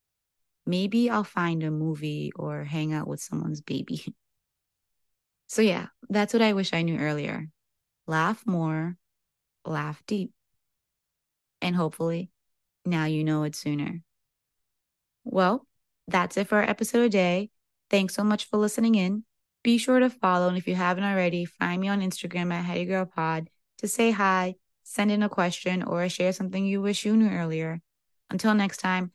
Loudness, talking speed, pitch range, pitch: -27 LUFS, 160 wpm, 165-210 Hz, 185 Hz